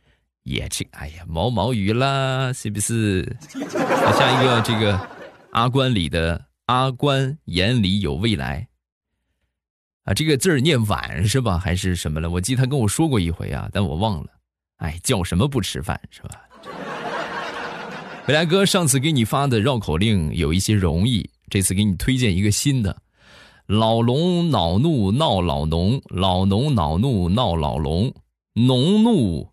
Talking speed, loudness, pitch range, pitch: 215 characters per minute, -20 LUFS, 90-130 Hz, 105 Hz